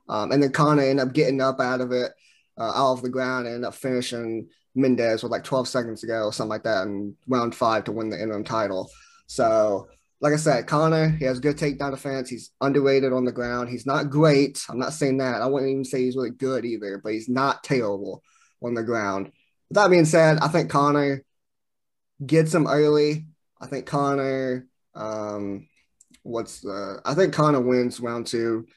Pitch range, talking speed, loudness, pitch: 120-145 Hz, 205 wpm, -23 LUFS, 130 Hz